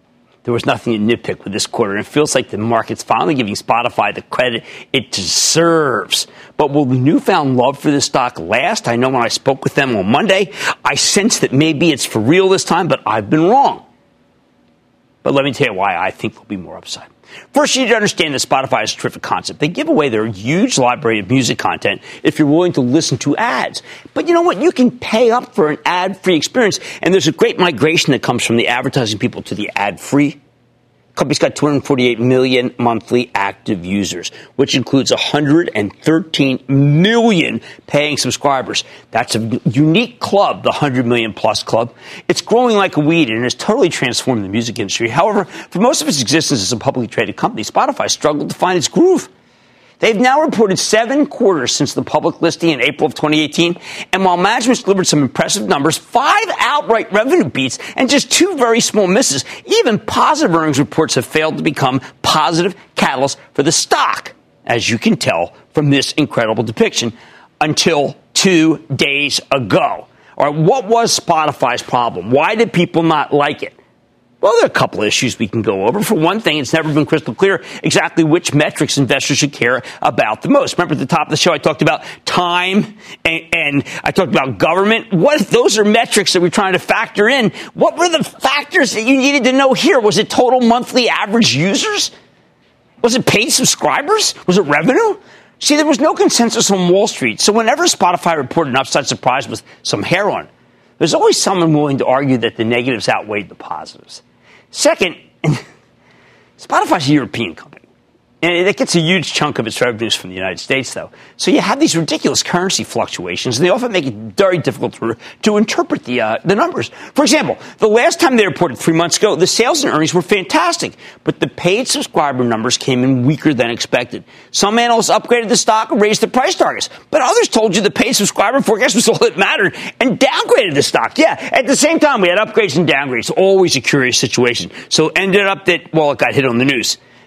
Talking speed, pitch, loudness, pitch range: 205 wpm, 165 Hz, -14 LUFS, 130-220 Hz